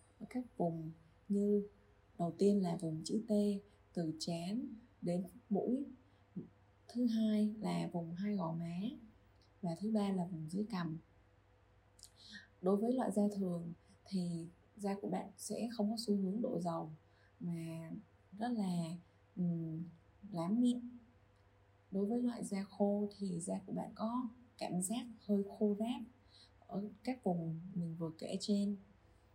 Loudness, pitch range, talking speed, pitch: -40 LUFS, 165-215 Hz, 145 wpm, 190 Hz